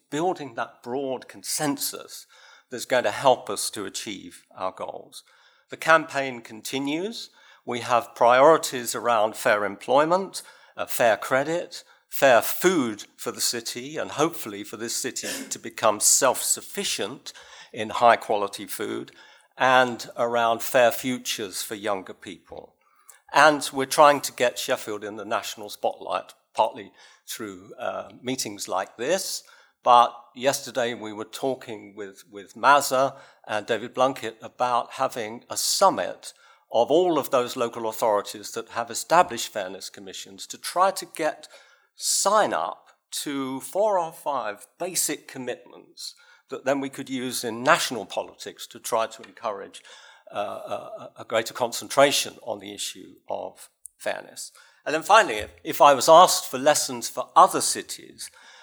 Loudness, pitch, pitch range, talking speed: -24 LUFS, 130 Hz, 115-140 Hz, 140 wpm